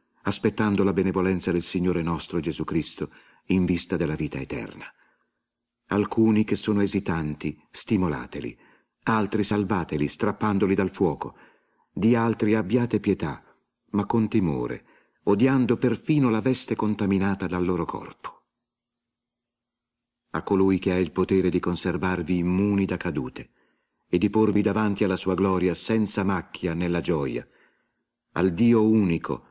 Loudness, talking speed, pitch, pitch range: -25 LUFS, 130 wpm, 100 Hz, 90-110 Hz